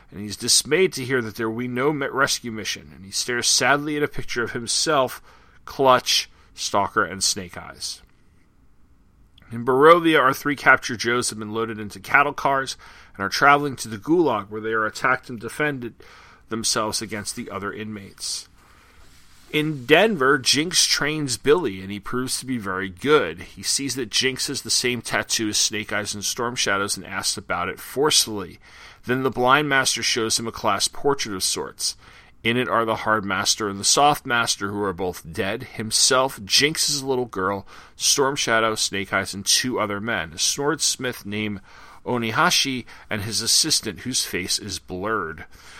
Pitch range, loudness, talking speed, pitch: 100-130 Hz, -21 LUFS, 175 wpm, 115 Hz